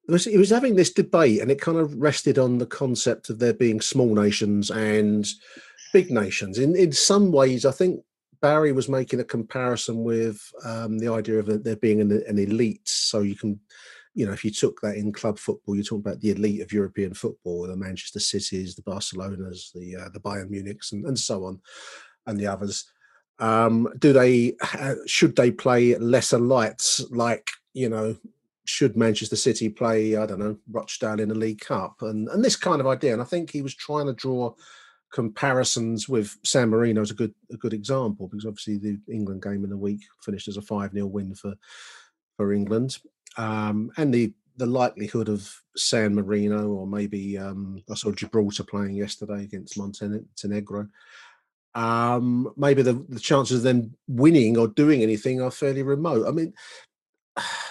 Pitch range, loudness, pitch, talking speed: 105-130 Hz, -24 LUFS, 110 Hz, 185 wpm